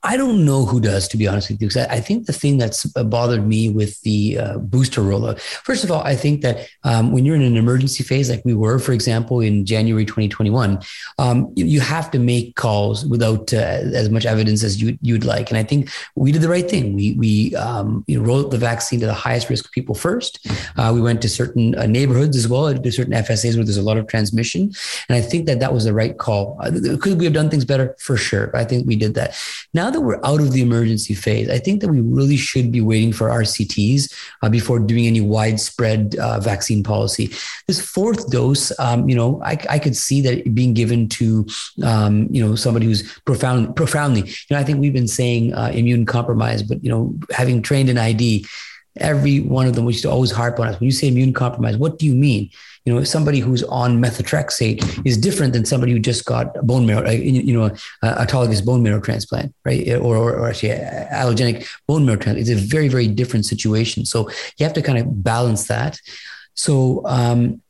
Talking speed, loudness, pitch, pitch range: 220 wpm, -18 LUFS, 120 Hz, 110-135 Hz